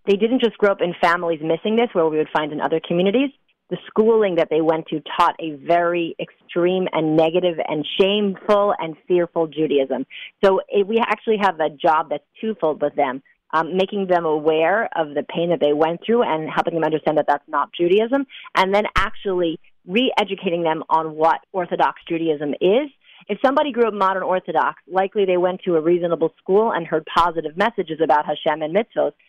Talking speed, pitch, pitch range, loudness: 190 wpm, 170 Hz, 160-200 Hz, -20 LUFS